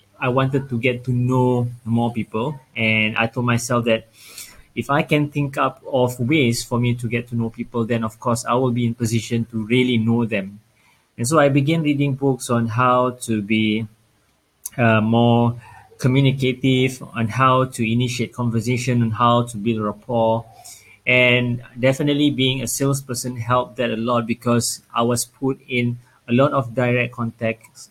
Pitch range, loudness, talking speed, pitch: 115-130 Hz, -20 LUFS, 175 wpm, 120 Hz